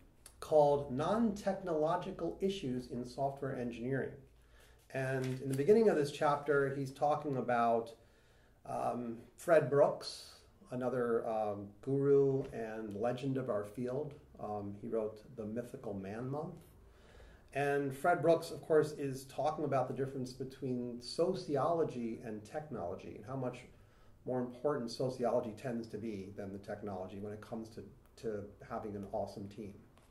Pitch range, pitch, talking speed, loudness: 110-140 Hz, 125 Hz, 140 wpm, -36 LUFS